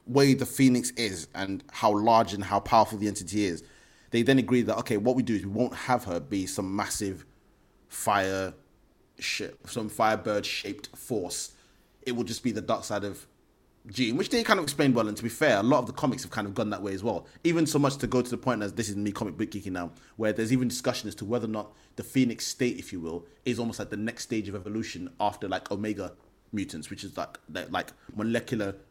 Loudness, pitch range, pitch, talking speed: -29 LUFS, 100-125 Hz, 110 Hz, 240 wpm